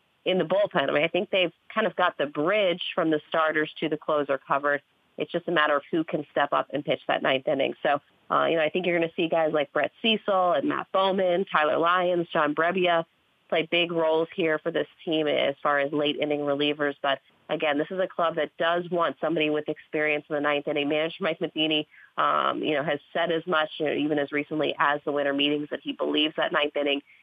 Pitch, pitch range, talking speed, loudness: 155 Hz, 150-170 Hz, 240 wpm, -26 LUFS